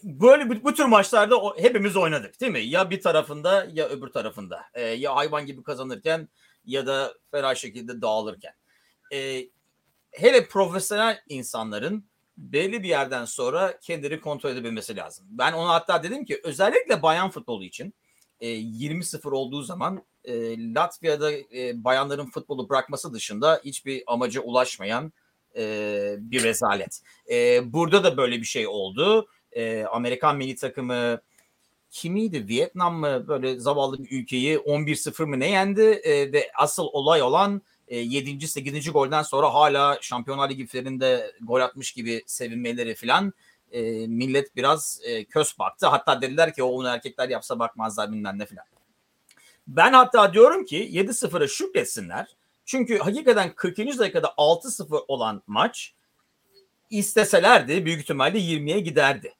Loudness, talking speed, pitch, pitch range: -23 LUFS, 135 wpm, 150 Hz, 130-210 Hz